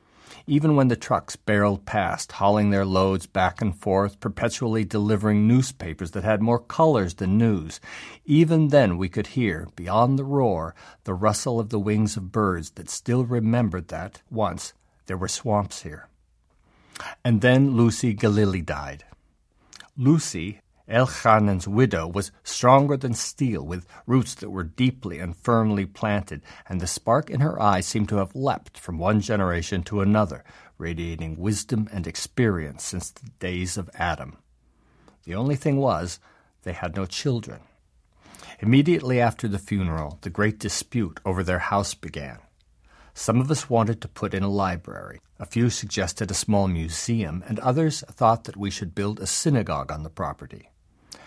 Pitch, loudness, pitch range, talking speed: 105 Hz, -24 LUFS, 90-115 Hz, 160 wpm